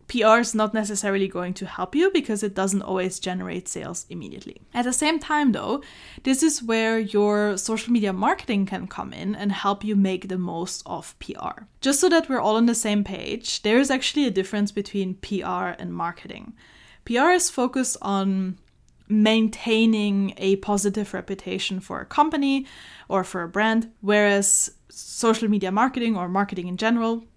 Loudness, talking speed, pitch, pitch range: -23 LUFS, 175 wpm, 210 Hz, 195-235 Hz